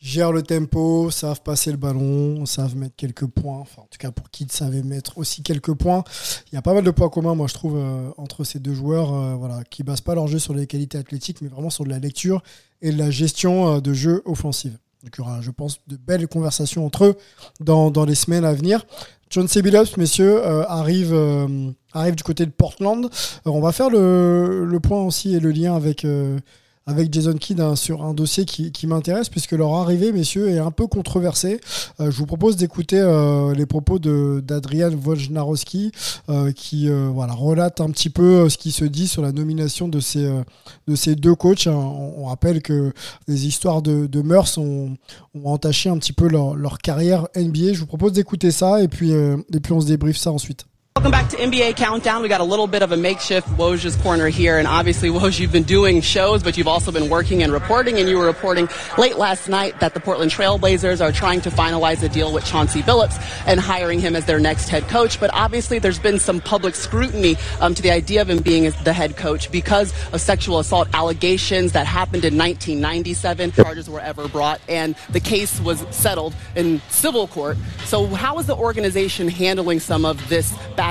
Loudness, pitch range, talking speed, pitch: -19 LUFS, 145-180 Hz, 215 wpm, 160 Hz